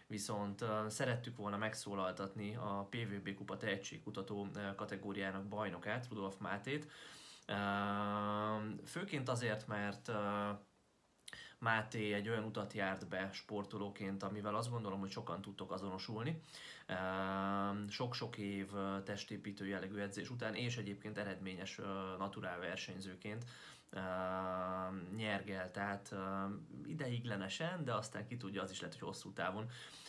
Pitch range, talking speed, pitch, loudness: 95-110 Hz, 105 wpm, 100 Hz, -43 LUFS